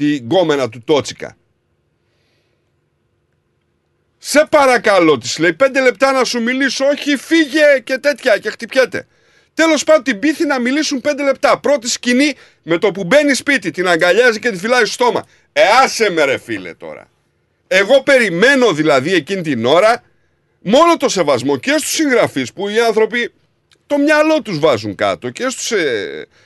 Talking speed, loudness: 160 wpm, -13 LUFS